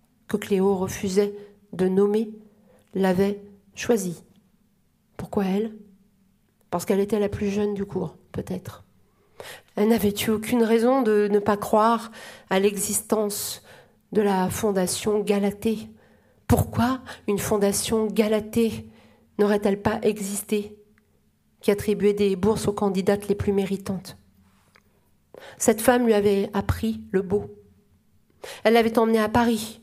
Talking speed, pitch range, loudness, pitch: 125 wpm, 195-215 Hz, -23 LUFS, 205 Hz